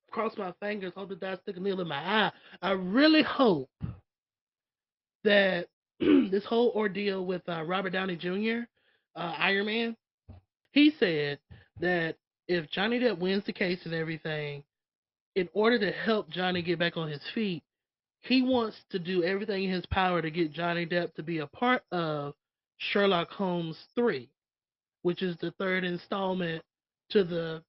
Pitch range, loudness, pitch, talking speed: 165-210 Hz, -29 LUFS, 185 Hz, 165 wpm